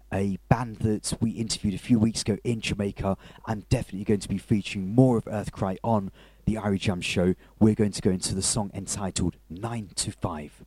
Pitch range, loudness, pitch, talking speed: 95-110 Hz, -27 LUFS, 105 Hz, 210 wpm